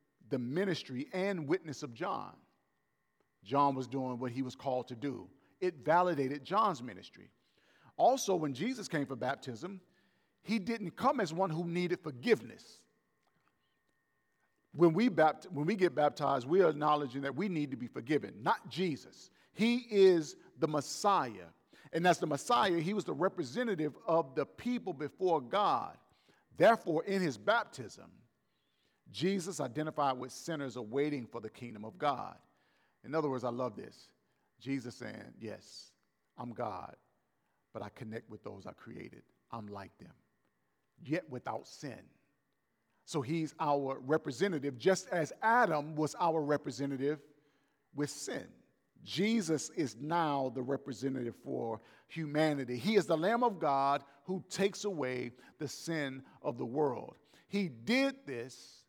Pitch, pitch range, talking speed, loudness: 150 Hz, 135-180 Hz, 145 wpm, -34 LUFS